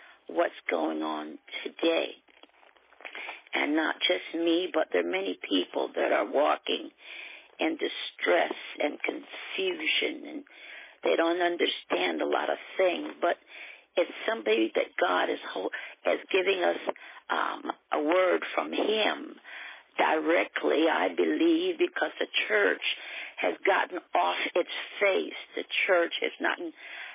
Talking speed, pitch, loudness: 130 wpm, 315 Hz, -28 LUFS